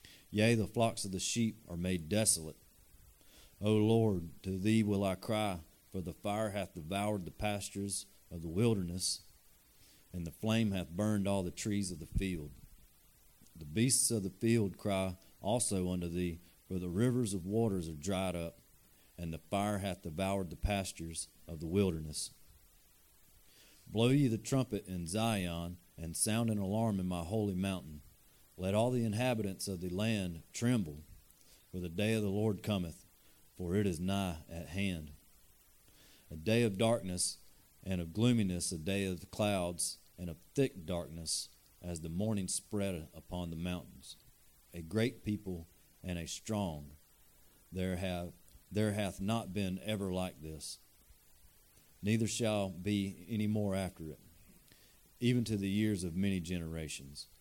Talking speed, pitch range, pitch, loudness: 155 wpm, 85-105 Hz, 95 Hz, -36 LUFS